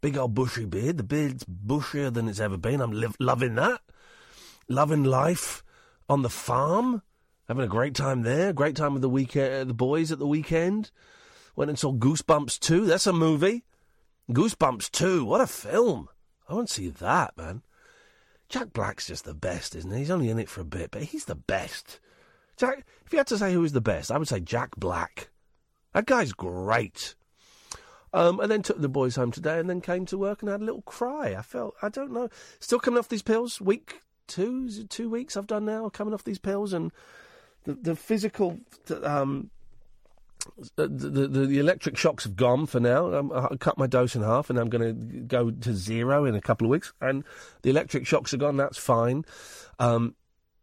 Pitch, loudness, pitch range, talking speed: 145 Hz, -27 LUFS, 125-210 Hz, 205 wpm